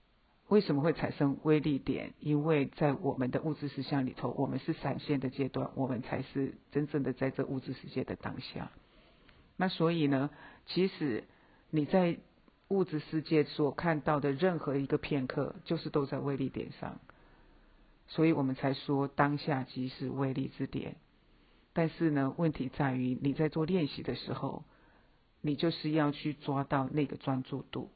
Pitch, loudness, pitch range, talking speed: 145 Hz, -33 LUFS, 135-155 Hz, 250 characters per minute